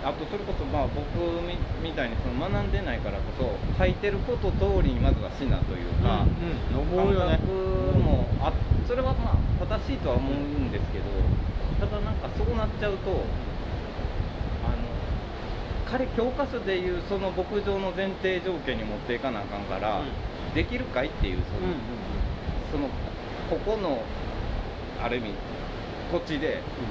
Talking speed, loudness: 270 characters per minute, -29 LUFS